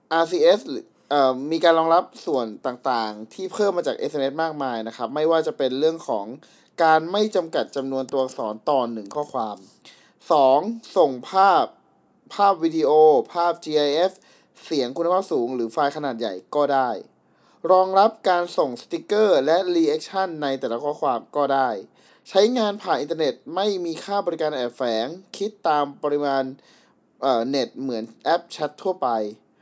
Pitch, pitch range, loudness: 160 Hz, 135-190 Hz, -22 LUFS